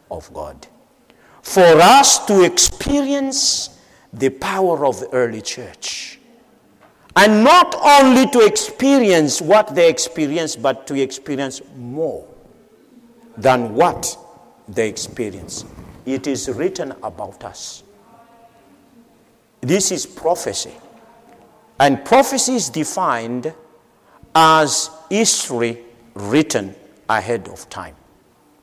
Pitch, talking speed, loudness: 160 Hz, 95 wpm, -15 LUFS